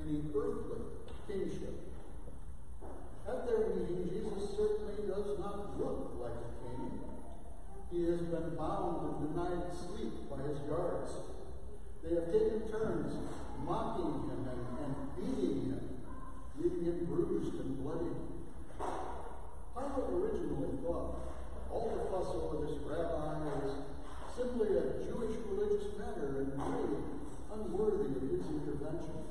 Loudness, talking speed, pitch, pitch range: -39 LUFS, 125 wpm, 175 Hz, 140-215 Hz